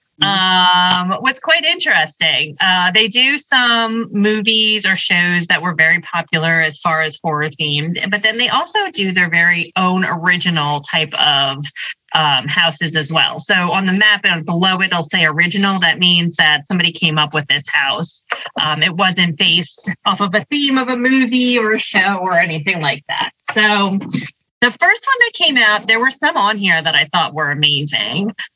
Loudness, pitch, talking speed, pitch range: -13 LUFS, 185 Hz, 185 wpm, 165-215 Hz